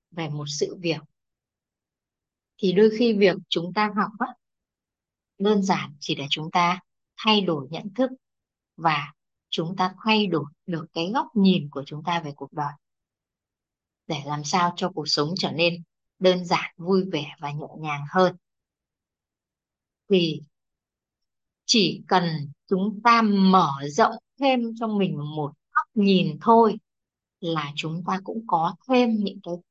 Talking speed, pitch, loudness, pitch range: 150 wpm, 175 Hz, -24 LUFS, 150-205 Hz